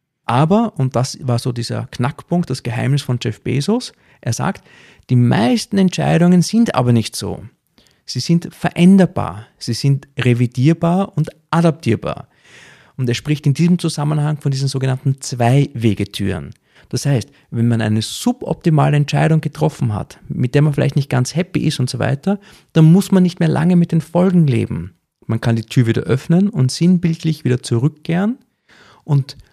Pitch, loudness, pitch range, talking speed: 145 Hz, -17 LUFS, 125-170 Hz, 165 wpm